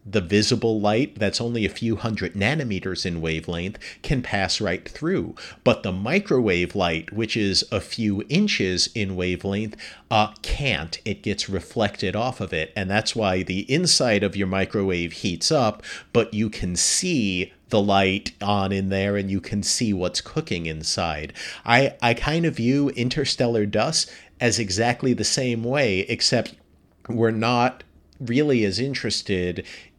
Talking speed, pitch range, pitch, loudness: 155 wpm, 95-120 Hz, 105 Hz, -23 LUFS